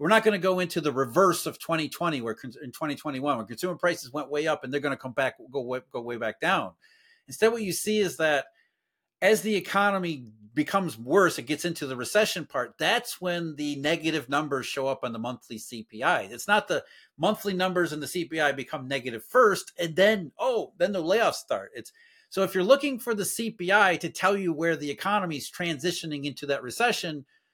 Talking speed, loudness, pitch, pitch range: 210 wpm, -27 LUFS, 165 Hz, 140-195 Hz